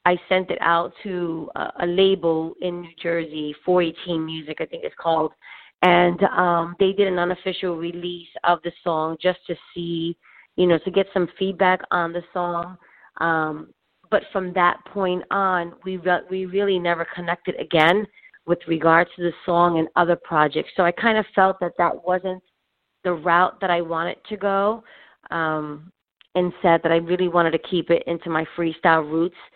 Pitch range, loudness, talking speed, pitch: 170-185 Hz, -22 LUFS, 180 wpm, 175 Hz